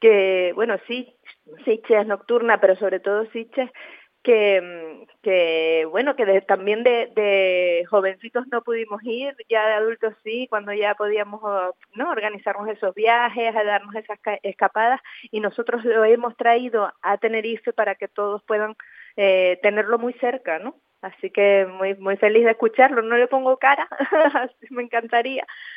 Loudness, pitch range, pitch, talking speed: -21 LUFS, 200-235 Hz, 215 Hz, 155 wpm